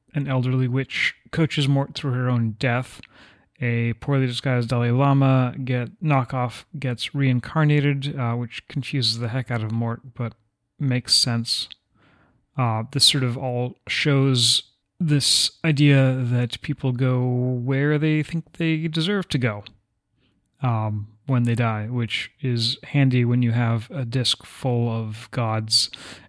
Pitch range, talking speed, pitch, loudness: 120-140 Hz, 140 wpm, 125 Hz, -22 LUFS